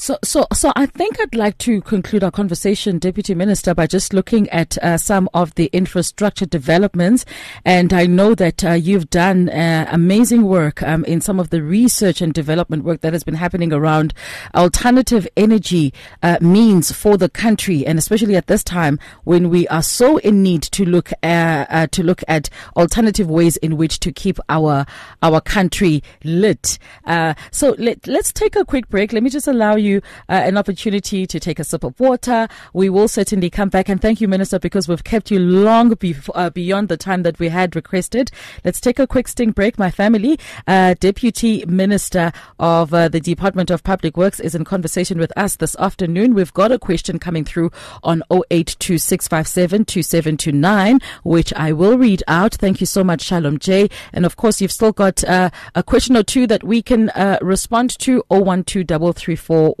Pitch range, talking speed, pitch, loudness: 165-210 Hz, 190 wpm, 185 Hz, -16 LUFS